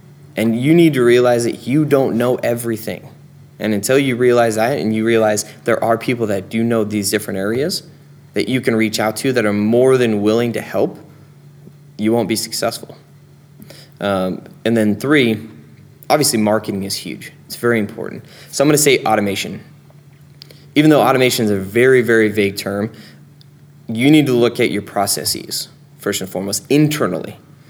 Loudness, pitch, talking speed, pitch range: -16 LUFS, 120 Hz, 175 wpm, 110-145 Hz